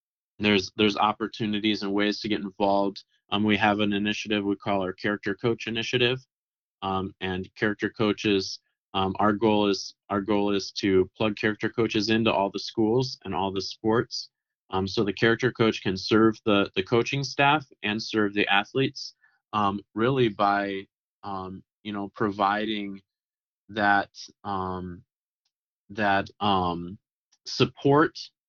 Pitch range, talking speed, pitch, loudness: 100-110 Hz, 145 wpm, 105 Hz, -26 LUFS